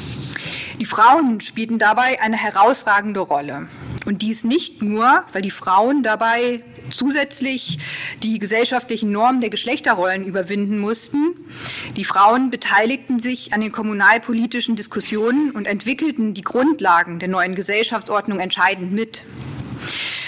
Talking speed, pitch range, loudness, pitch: 120 wpm, 200-245 Hz, -18 LUFS, 220 Hz